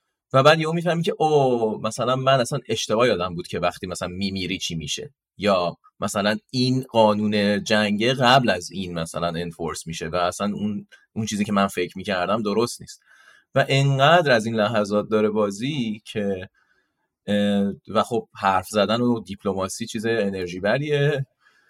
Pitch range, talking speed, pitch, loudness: 95-125 Hz, 160 wpm, 105 Hz, -22 LUFS